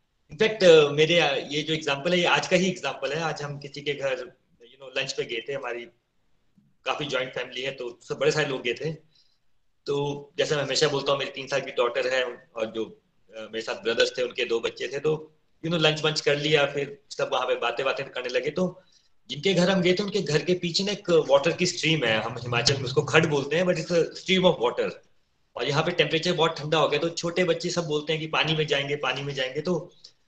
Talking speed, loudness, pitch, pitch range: 215 wpm, -25 LUFS, 155 Hz, 140-180 Hz